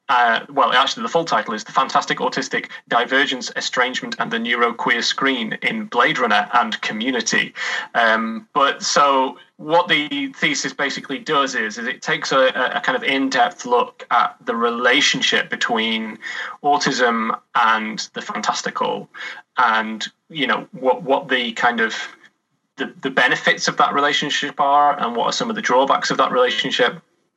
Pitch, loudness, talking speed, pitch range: 140 Hz, -18 LUFS, 160 wpm, 120-175 Hz